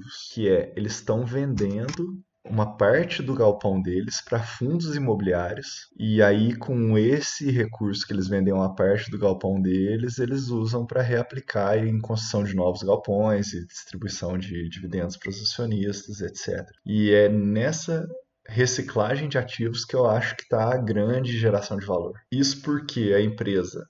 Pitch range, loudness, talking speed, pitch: 100-125 Hz, -25 LUFS, 160 wpm, 110 Hz